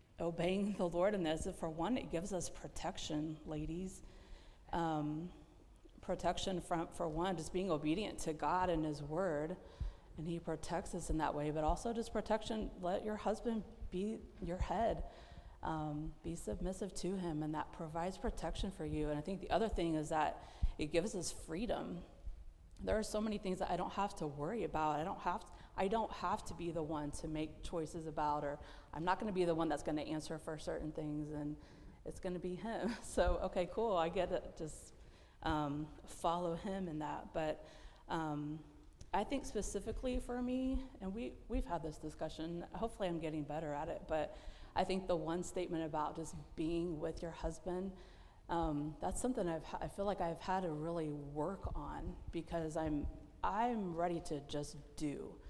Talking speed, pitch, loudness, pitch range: 185 wpm, 170 Hz, -41 LUFS, 155-190 Hz